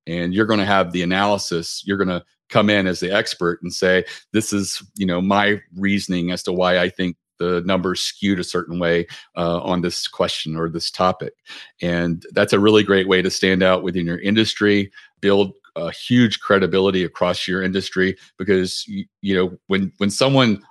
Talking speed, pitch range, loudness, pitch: 190 wpm, 90-100 Hz, -19 LUFS, 95 Hz